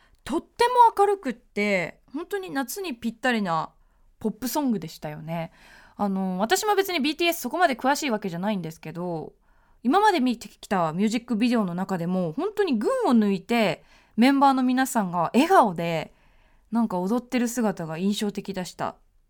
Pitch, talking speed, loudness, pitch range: 225 Hz, 355 characters per minute, -24 LUFS, 185-280 Hz